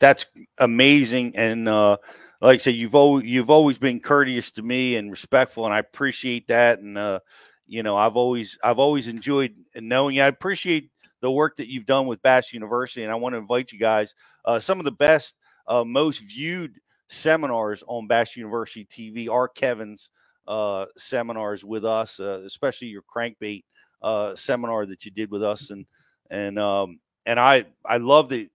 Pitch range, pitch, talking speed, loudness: 110-135 Hz, 120 Hz, 185 wpm, -22 LUFS